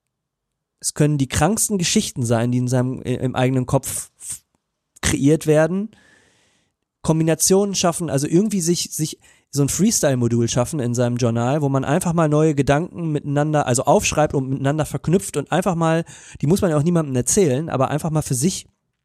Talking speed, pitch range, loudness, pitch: 175 wpm, 130-165 Hz, -19 LUFS, 150 Hz